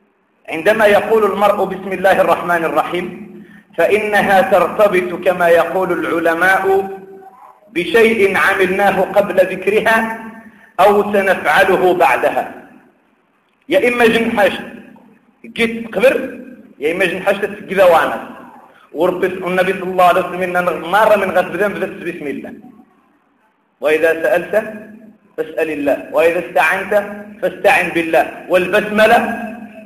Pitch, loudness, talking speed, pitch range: 195 Hz, -14 LUFS, 95 wpm, 180-220 Hz